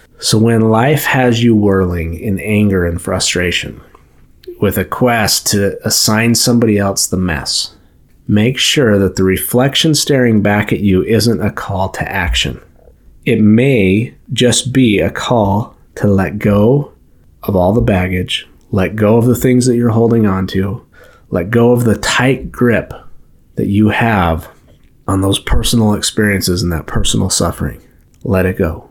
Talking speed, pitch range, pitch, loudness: 160 wpm, 95-120 Hz, 105 Hz, -13 LUFS